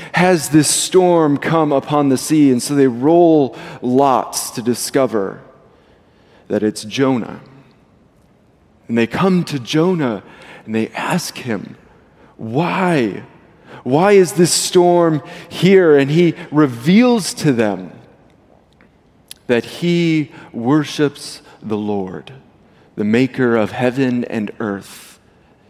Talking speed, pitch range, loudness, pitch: 110 wpm, 120-170 Hz, -15 LUFS, 145 Hz